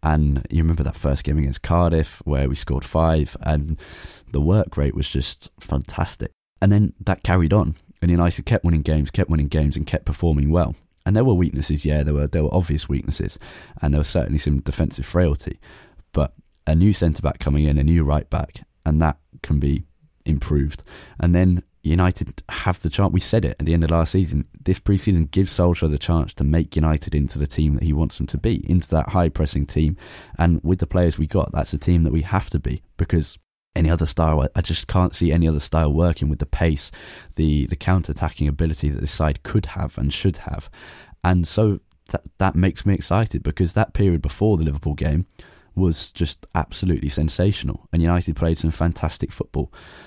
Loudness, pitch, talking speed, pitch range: -21 LUFS, 80 Hz, 210 wpm, 75-90 Hz